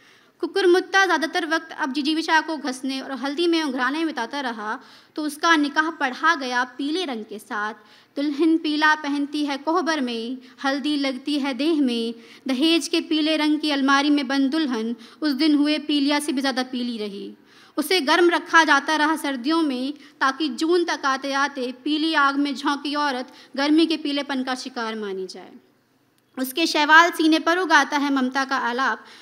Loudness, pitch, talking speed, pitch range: -21 LUFS, 290 Hz, 170 wpm, 265-315 Hz